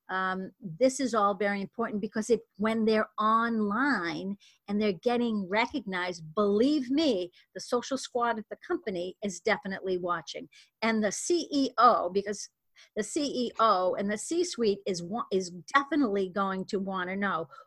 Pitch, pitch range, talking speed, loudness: 210 Hz, 190-240 Hz, 150 wpm, -29 LUFS